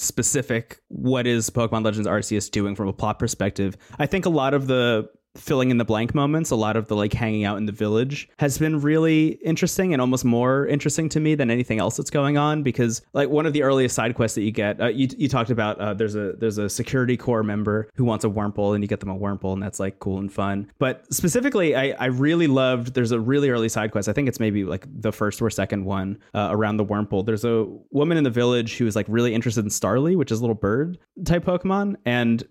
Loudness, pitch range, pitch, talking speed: -22 LUFS, 105-140 Hz, 115 Hz, 250 wpm